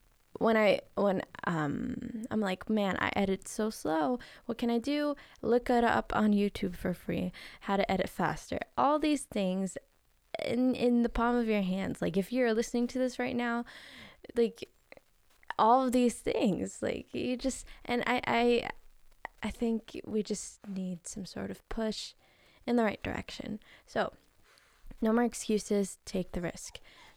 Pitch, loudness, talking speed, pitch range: 235 Hz, -32 LUFS, 165 wpm, 205-245 Hz